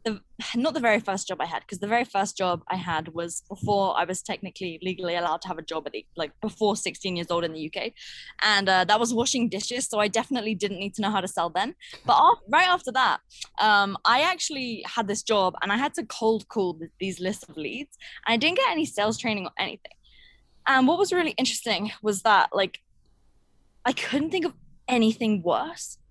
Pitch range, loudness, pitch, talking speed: 185-240 Hz, -25 LUFS, 210 Hz, 225 wpm